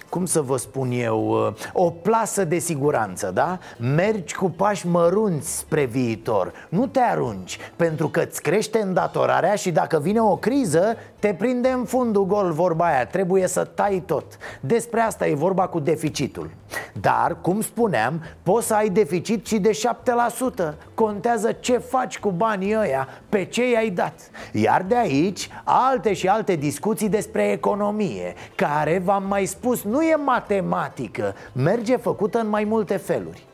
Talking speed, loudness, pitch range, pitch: 155 wpm, -22 LUFS, 170-225 Hz, 200 Hz